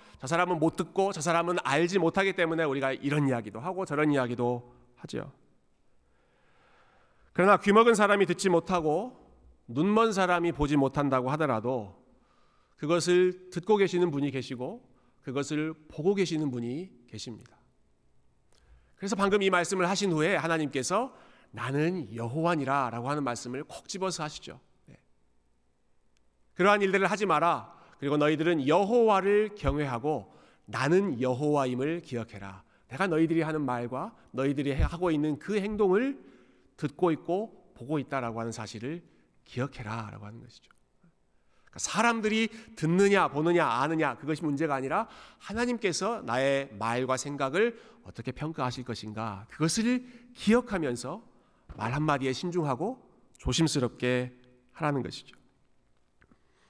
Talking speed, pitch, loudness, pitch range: 310 characters per minute, 150 Hz, -28 LUFS, 125-180 Hz